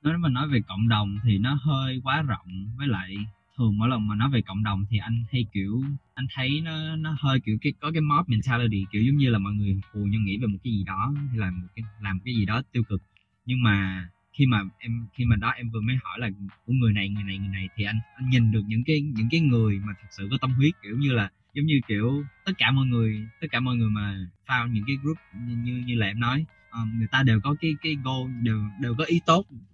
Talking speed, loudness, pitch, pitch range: 270 wpm, -26 LUFS, 115 Hz, 105-130 Hz